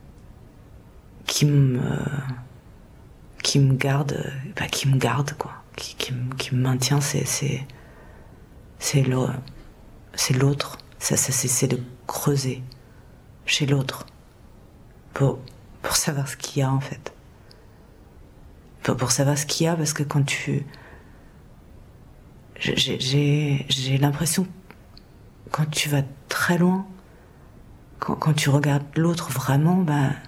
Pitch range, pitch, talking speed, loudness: 130-145 Hz, 140 Hz, 125 wpm, -23 LUFS